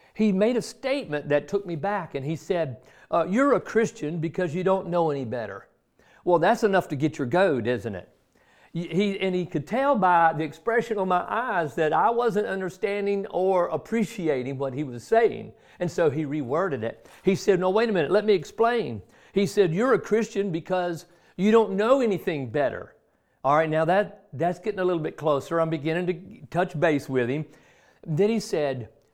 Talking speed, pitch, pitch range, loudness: 200 wpm, 175 Hz, 155-205 Hz, -25 LUFS